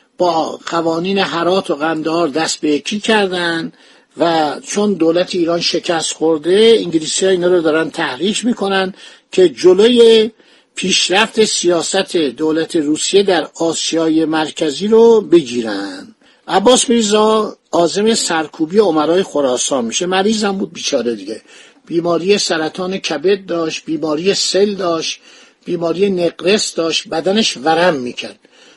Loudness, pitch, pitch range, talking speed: -14 LUFS, 180 Hz, 165-210 Hz, 120 wpm